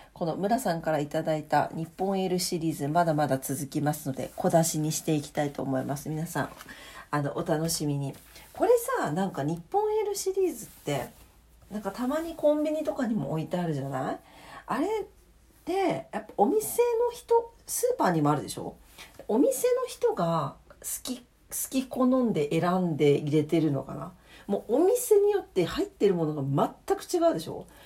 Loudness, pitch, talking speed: -28 LUFS, 180 Hz, 350 characters per minute